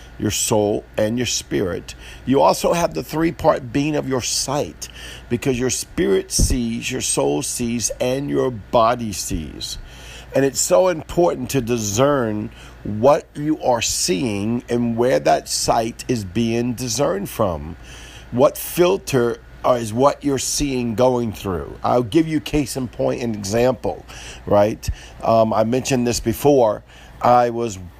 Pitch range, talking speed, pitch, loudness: 105-135 Hz, 145 wpm, 120 Hz, -19 LUFS